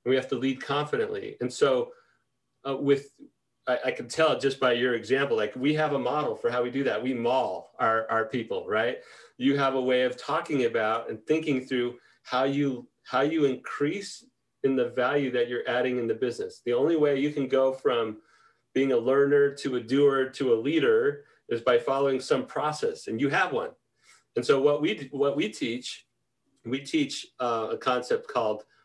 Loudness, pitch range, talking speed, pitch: -27 LUFS, 130-205 Hz, 200 wpm, 140 Hz